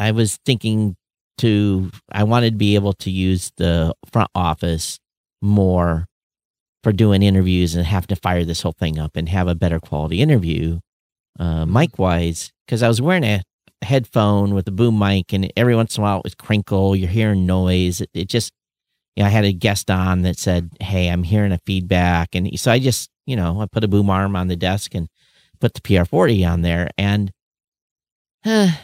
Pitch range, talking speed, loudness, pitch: 90-110 Hz, 200 wpm, -18 LUFS, 95 Hz